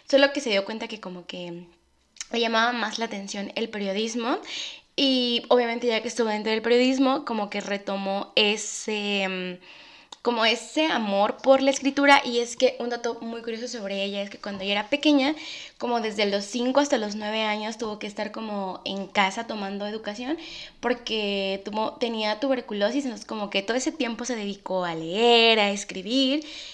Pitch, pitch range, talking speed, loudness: 225 Hz, 205-255 Hz, 180 wpm, -25 LUFS